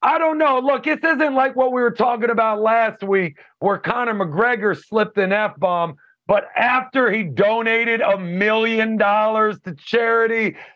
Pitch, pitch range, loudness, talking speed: 225 Hz, 205-250 Hz, -18 LUFS, 165 wpm